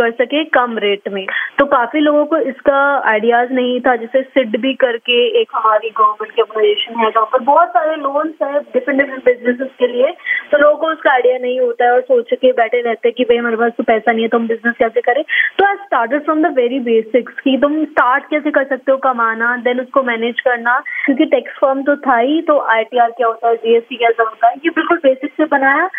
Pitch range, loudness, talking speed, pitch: 235-295 Hz, -14 LUFS, 210 wpm, 260 Hz